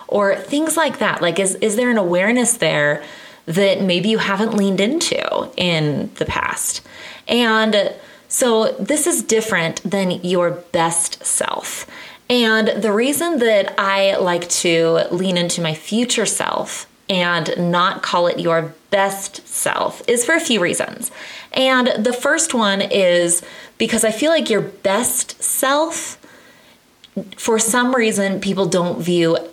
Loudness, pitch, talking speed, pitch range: -17 LUFS, 200 Hz, 145 wpm, 175-245 Hz